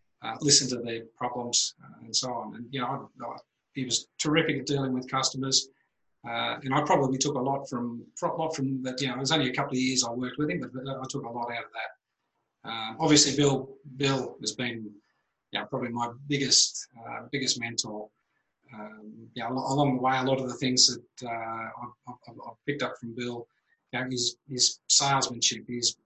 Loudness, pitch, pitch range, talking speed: -27 LUFS, 130 Hz, 120-135 Hz, 210 wpm